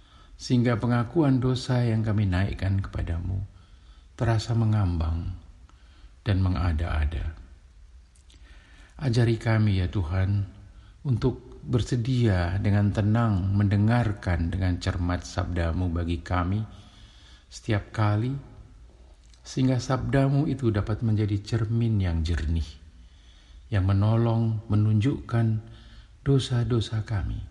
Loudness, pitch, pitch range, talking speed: -26 LUFS, 100 Hz, 85-115 Hz, 85 wpm